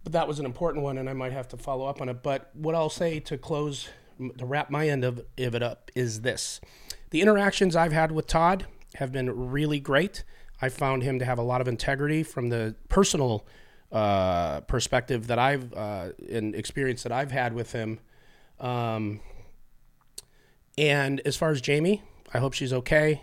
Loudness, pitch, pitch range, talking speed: -27 LUFS, 135 Hz, 120-150 Hz, 195 wpm